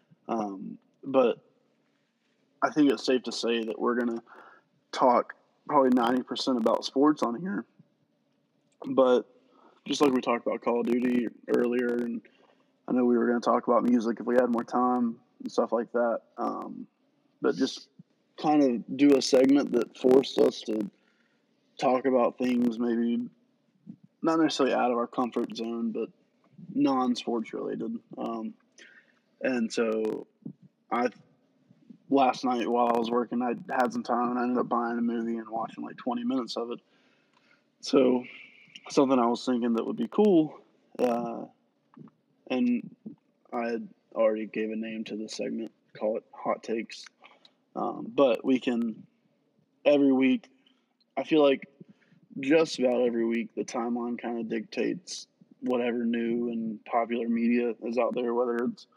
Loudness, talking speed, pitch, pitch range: -28 LUFS, 155 wpm, 125 Hz, 120-165 Hz